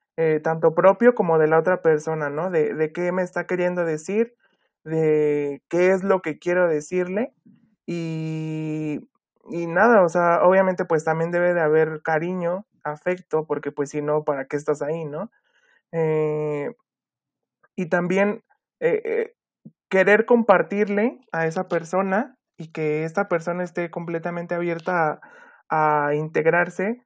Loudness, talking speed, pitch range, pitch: -22 LUFS, 140 wpm, 155-190 Hz, 170 Hz